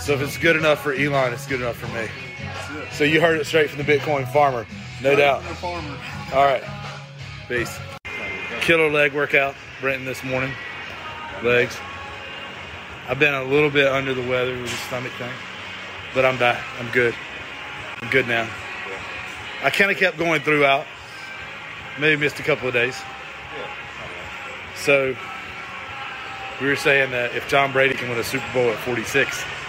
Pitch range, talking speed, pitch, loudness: 120-145 Hz, 160 wpm, 135 Hz, -21 LUFS